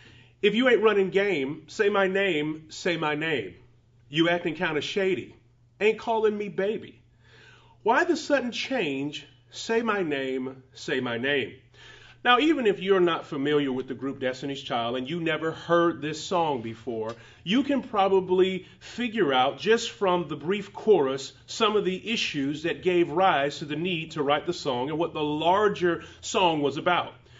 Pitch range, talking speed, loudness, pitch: 140-200 Hz, 175 wpm, -26 LUFS, 170 Hz